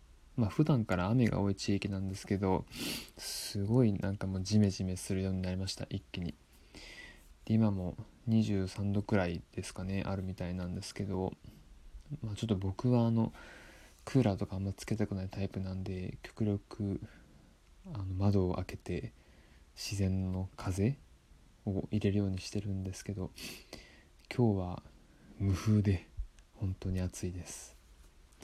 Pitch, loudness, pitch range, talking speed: 95 Hz, -35 LUFS, 90-105 Hz, 285 characters per minute